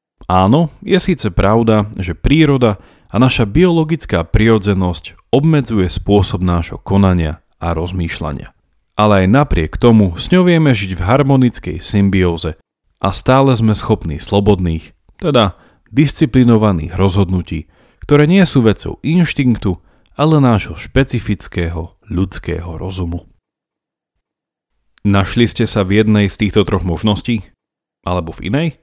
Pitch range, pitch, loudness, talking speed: 90-125 Hz, 100 Hz, -14 LUFS, 120 wpm